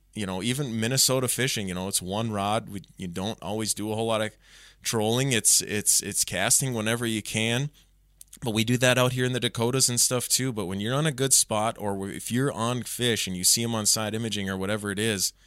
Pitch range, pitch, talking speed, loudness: 100-125 Hz, 110 Hz, 240 wpm, -24 LUFS